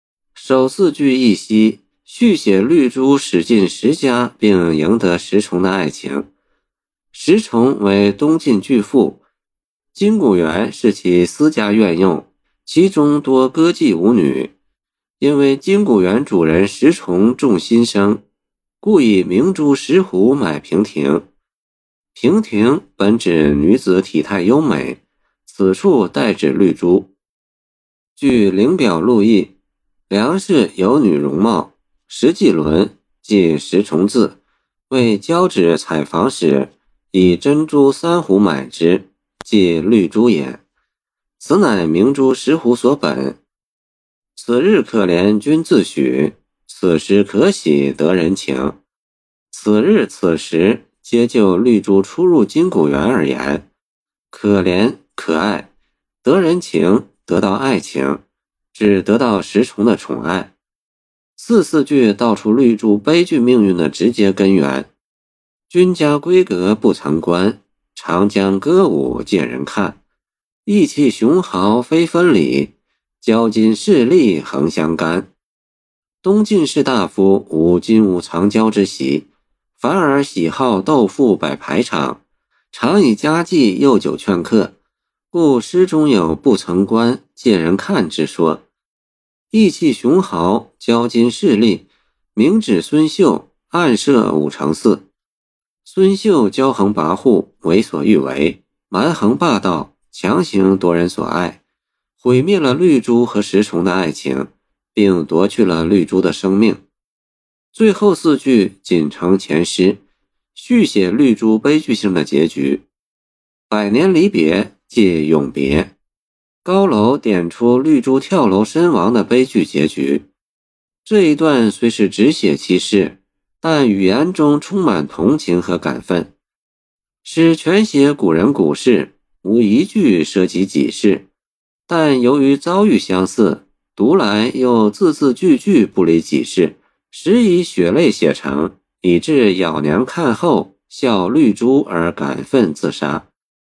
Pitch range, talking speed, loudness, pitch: 90-140 Hz, 180 characters per minute, -14 LUFS, 105 Hz